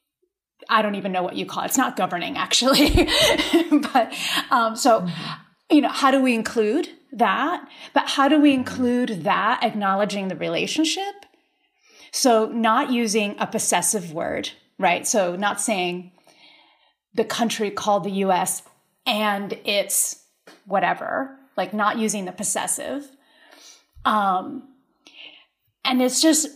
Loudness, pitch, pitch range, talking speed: -21 LUFS, 245 Hz, 210-300 Hz, 130 wpm